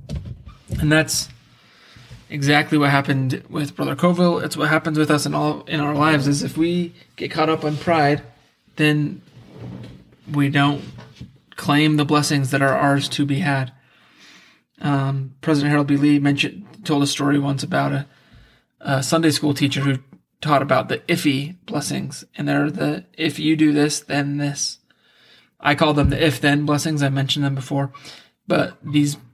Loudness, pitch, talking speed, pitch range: -20 LUFS, 145 Hz, 165 wpm, 140-155 Hz